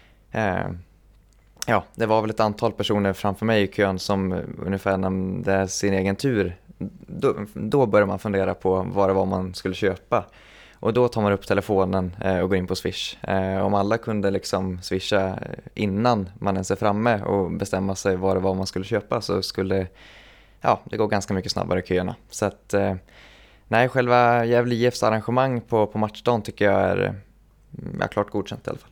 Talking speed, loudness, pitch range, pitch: 185 wpm, -23 LUFS, 95-110 Hz, 100 Hz